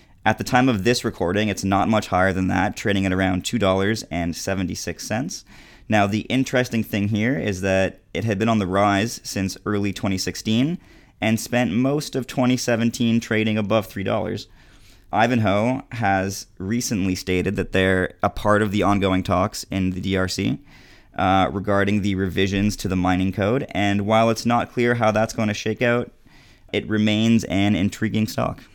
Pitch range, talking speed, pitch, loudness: 95-115 Hz, 165 wpm, 105 Hz, -21 LUFS